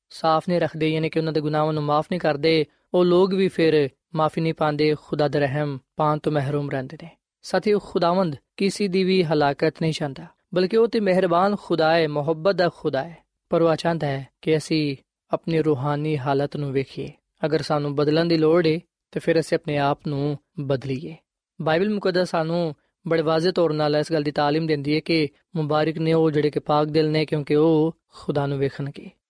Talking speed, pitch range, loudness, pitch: 175 wpm, 150-170 Hz, -22 LUFS, 155 Hz